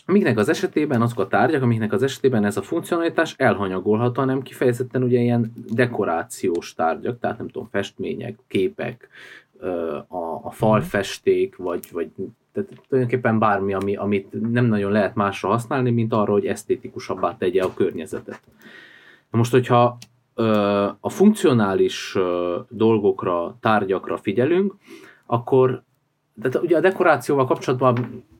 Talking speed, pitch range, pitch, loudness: 125 wpm, 105-135 Hz, 120 Hz, -21 LUFS